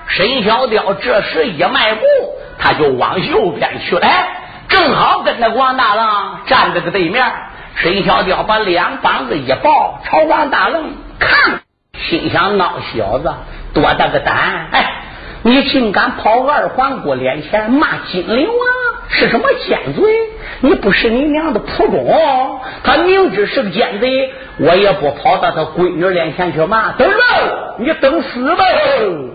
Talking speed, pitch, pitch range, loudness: 215 characters per minute, 260 Hz, 205-315 Hz, -13 LUFS